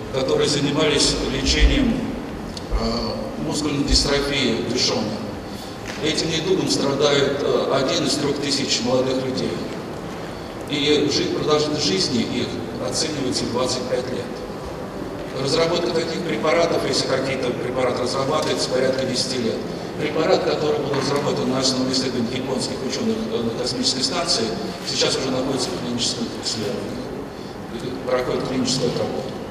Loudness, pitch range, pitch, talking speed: -21 LUFS, 130-150 Hz, 140 Hz, 115 wpm